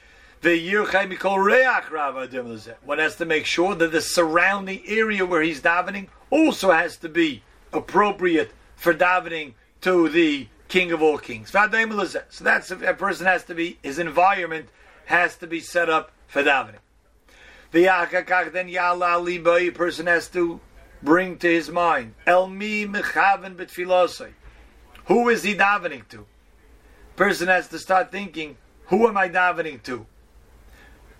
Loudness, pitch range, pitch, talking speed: -21 LUFS, 165-195 Hz, 175 Hz, 130 wpm